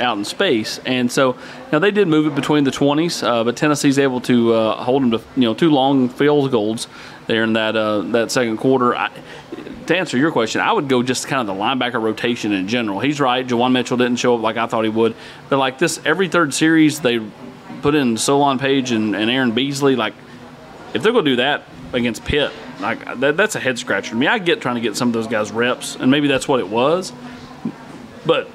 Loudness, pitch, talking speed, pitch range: -17 LUFS, 125 Hz, 230 wpm, 115-140 Hz